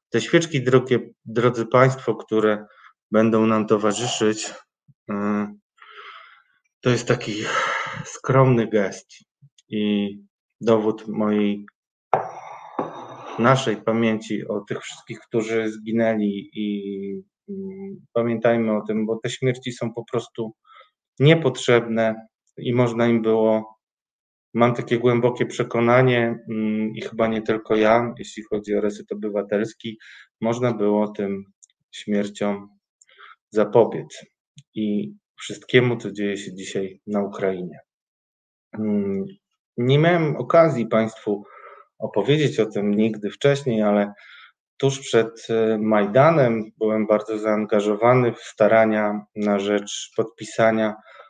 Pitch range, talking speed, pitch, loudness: 105-125 Hz, 100 wpm, 110 Hz, -22 LUFS